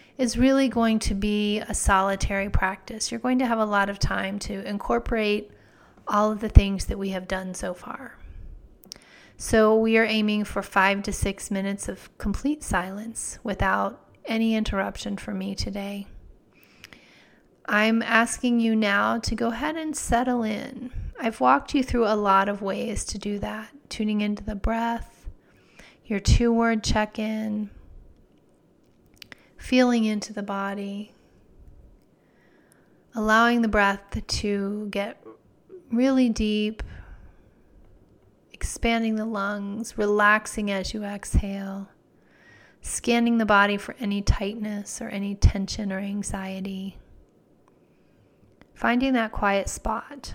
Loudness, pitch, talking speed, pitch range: -25 LUFS, 210 Hz, 130 wpm, 200-230 Hz